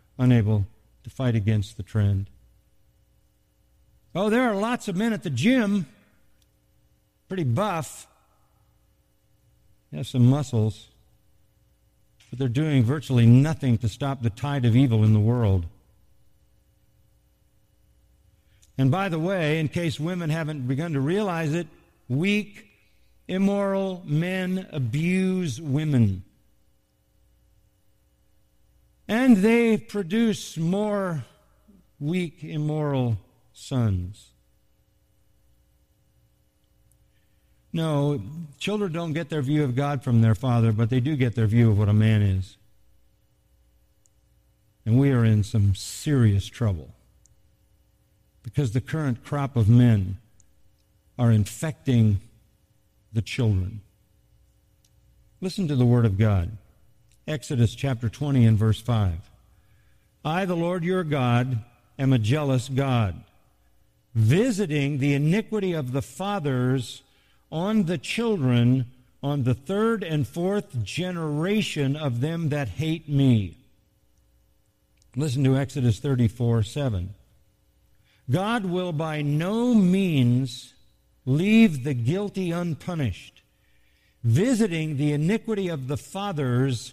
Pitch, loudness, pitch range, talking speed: 130 Hz, -24 LUFS, 110-165 Hz, 110 wpm